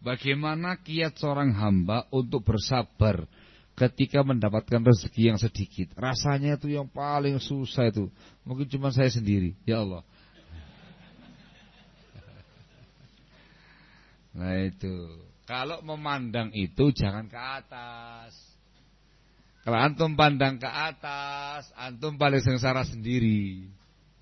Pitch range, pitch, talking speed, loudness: 105-140 Hz, 125 Hz, 100 wpm, -27 LUFS